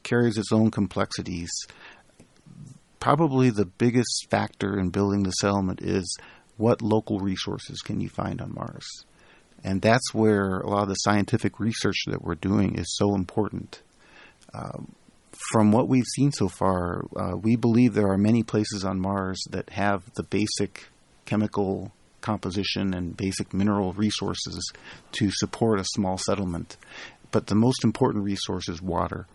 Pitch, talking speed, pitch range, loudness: 100 Hz, 150 wpm, 95-110 Hz, -25 LUFS